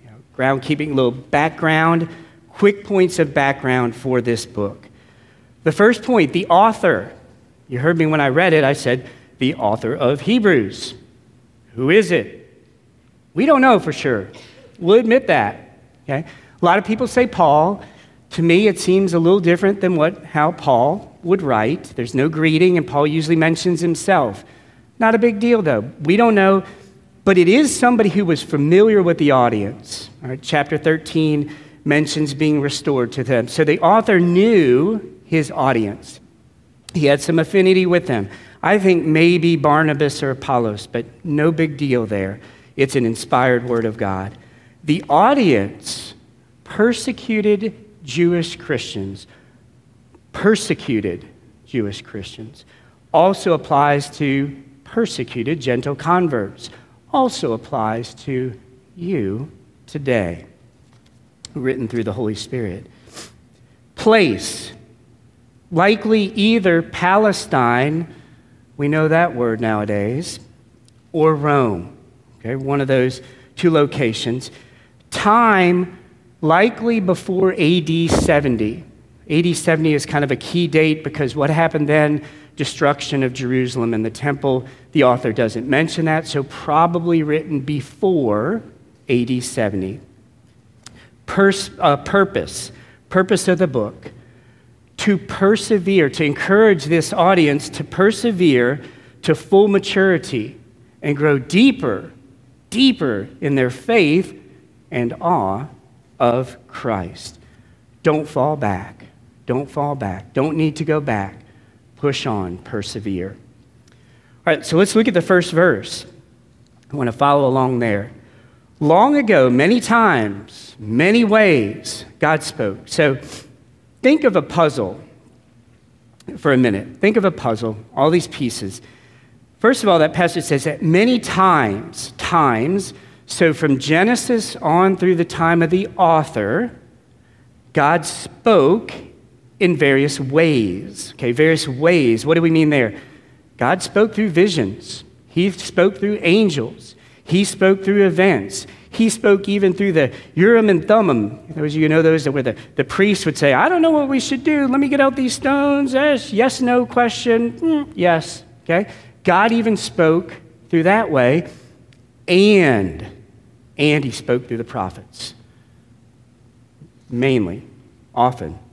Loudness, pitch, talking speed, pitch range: -17 LUFS, 150 Hz, 135 wpm, 120-180 Hz